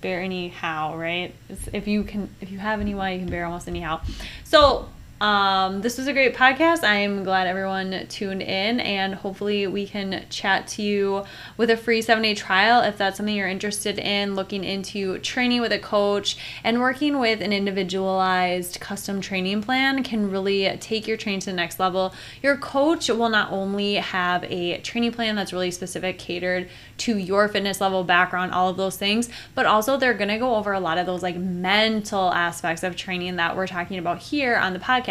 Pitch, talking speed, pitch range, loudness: 195 Hz, 205 wpm, 185-215 Hz, -23 LUFS